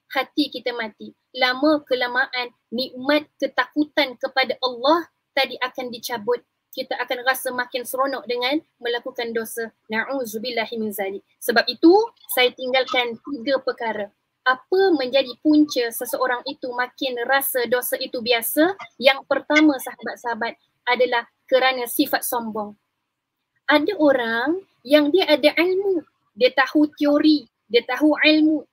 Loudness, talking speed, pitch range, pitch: -21 LUFS, 115 wpm, 245-295 Hz, 260 Hz